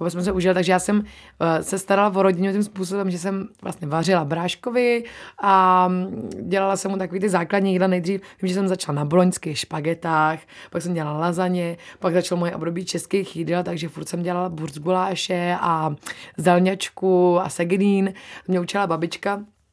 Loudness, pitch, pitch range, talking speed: -22 LUFS, 185 Hz, 170-195 Hz, 165 wpm